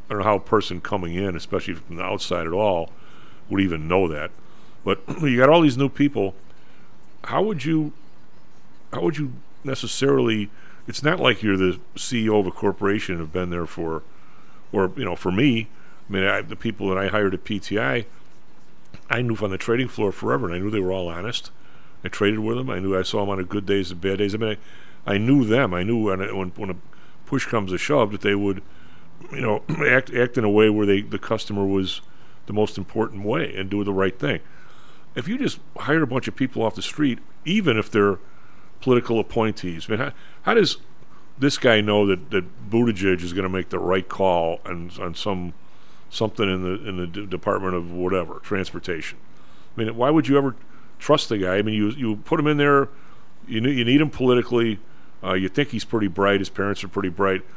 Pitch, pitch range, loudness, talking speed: 105 Hz, 95-115 Hz, -23 LUFS, 220 wpm